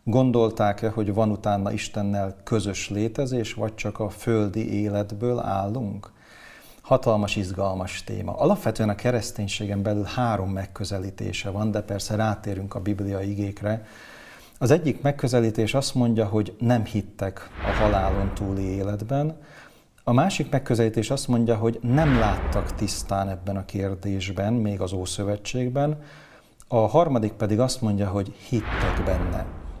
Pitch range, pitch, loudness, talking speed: 100-115 Hz, 105 Hz, -25 LUFS, 130 wpm